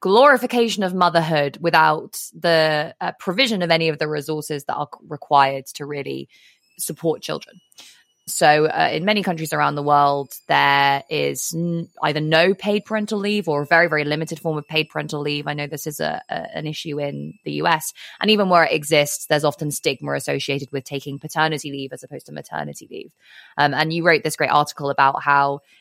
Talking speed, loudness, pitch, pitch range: 195 wpm, -20 LUFS, 155 Hz, 145-170 Hz